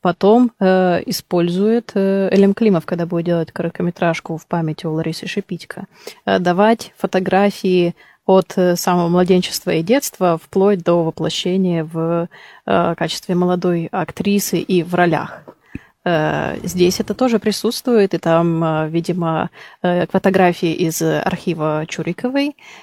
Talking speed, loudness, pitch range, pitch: 130 wpm, -17 LUFS, 170-195 Hz, 180 Hz